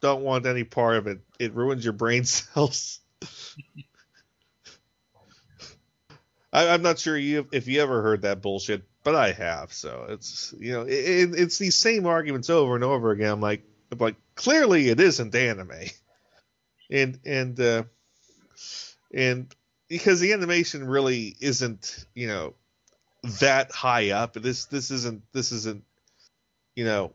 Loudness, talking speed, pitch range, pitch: -24 LUFS, 150 wpm, 110-140 Hz, 125 Hz